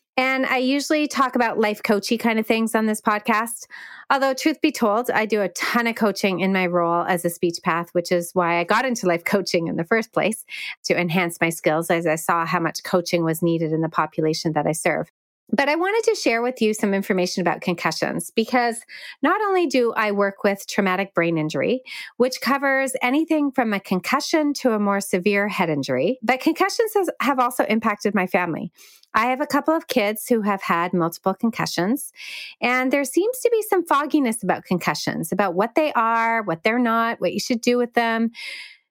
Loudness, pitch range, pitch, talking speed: -21 LUFS, 180-260 Hz, 220 Hz, 205 wpm